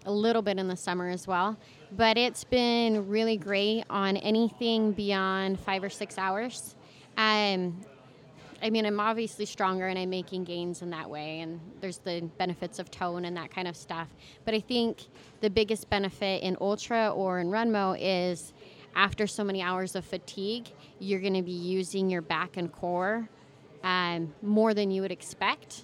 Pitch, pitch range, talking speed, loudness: 190 Hz, 180-215 Hz, 180 wpm, -30 LUFS